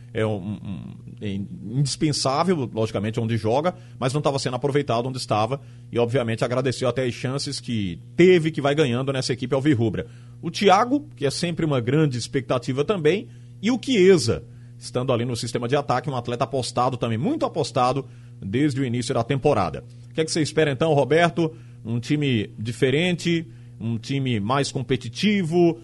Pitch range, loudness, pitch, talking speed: 120-145 Hz, -23 LUFS, 130 Hz, 170 wpm